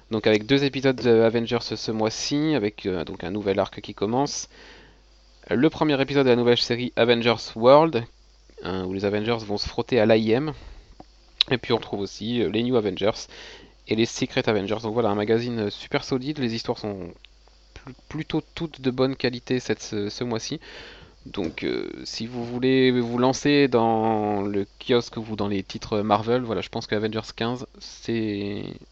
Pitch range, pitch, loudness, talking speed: 105-130 Hz, 115 Hz, -24 LUFS, 180 wpm